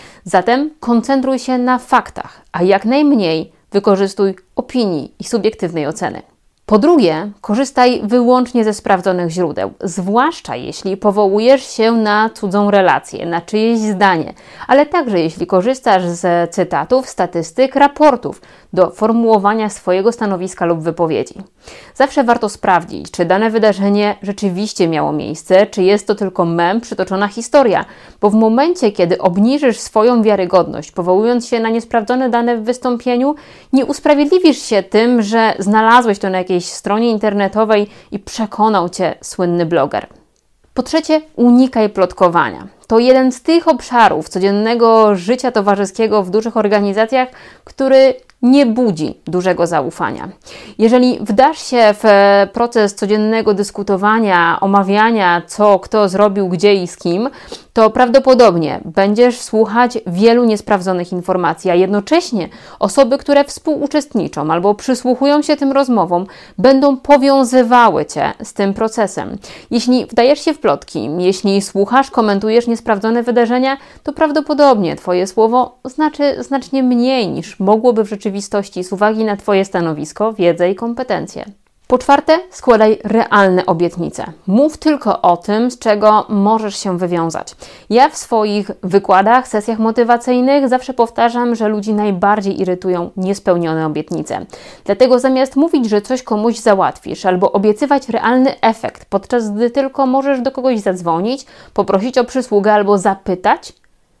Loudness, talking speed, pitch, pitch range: -13 LUFS, 130 wpm, 215 Hz, 195-250 Hz